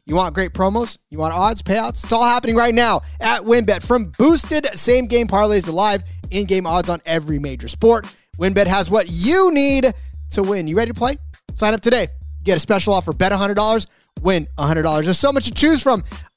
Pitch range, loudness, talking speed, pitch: 170-235 Hz, -17 LUFS, 210 wpm, 200 Hz